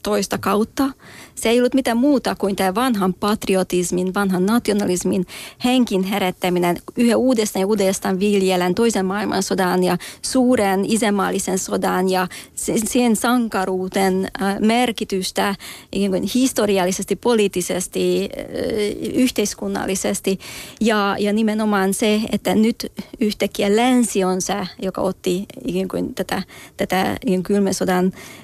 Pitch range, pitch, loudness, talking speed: 190-225 Hz, 200 Hz, -19 LUFS, 105 wpm